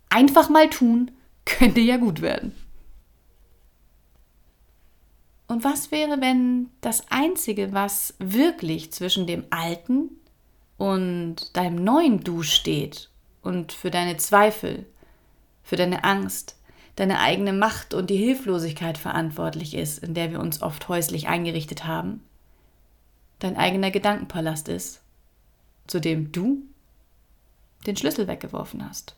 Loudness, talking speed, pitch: -23 LUFS, 115 wpm, 175 Hz